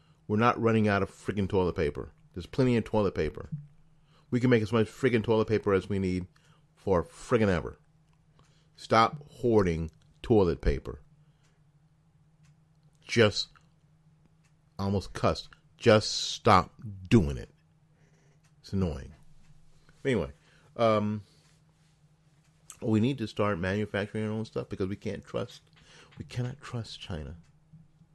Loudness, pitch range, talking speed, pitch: -29 LUFS, 105-155 Hz, 125 wpm, 125 Hz